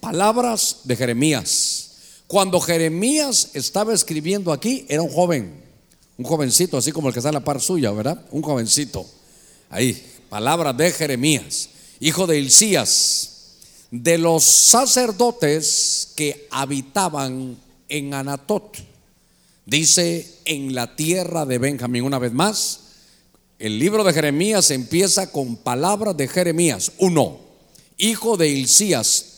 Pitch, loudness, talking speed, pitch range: 155 Hz, -18 LUFS, 125 wpm, 135-185 Hz